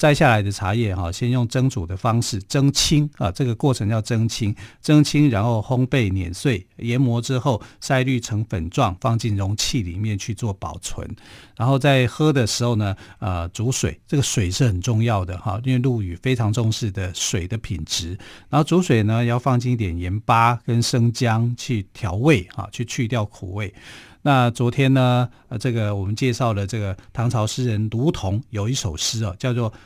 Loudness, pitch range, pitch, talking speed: -21 LUFS, 105-130 Hz, 115 Hz, 270 characters per minute